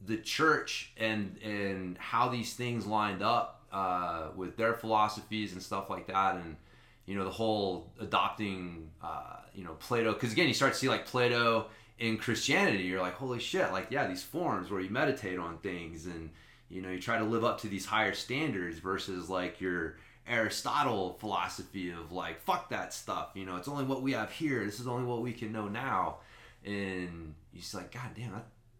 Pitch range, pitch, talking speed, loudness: 90-115 Hz, 100 Hz, 200 wpm, -33 LUFS